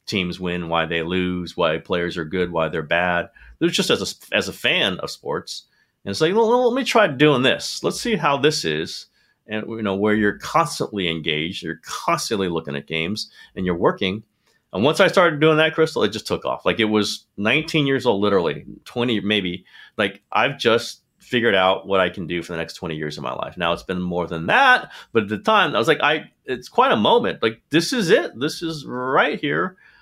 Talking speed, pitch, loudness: 225 wpm, 105 Hz, -20 LUFS